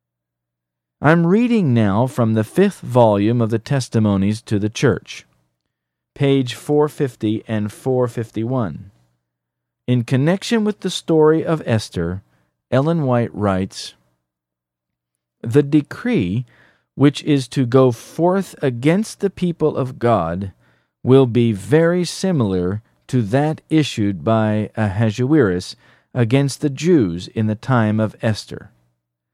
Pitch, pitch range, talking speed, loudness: 120 Hz, 95-145 Hz, 115 wpm, -18 LUFS